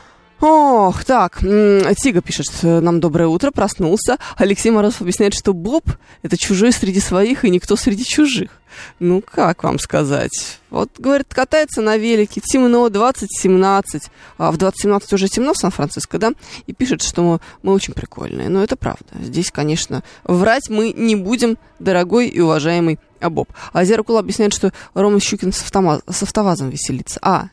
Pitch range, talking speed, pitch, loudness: 180-230 Hz, 155 wpm, 200 Hz, -16 LUFS